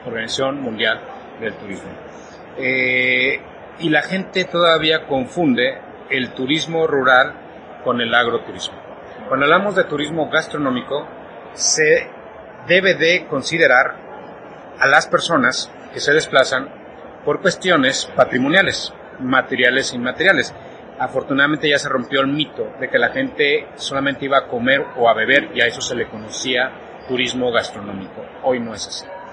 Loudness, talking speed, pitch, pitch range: -17 LUFS, 135 wpm, 150 Hz, 135-180 Hz